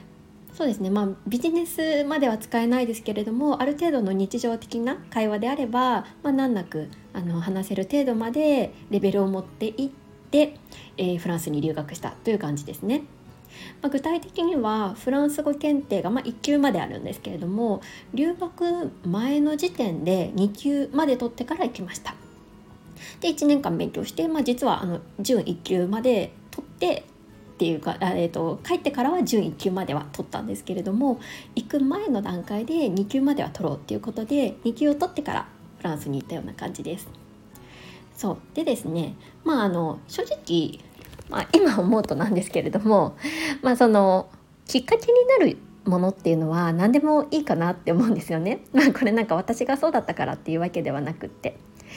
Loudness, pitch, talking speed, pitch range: -25 LUFS, 230 Hz, 360 characters per minute, 185-285 Hz